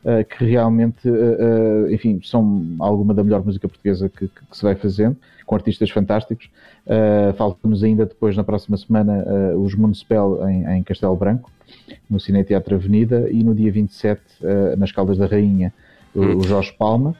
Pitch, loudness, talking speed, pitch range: 105 Hz, -18 LUFS, 180 wpm, 100-110 Hz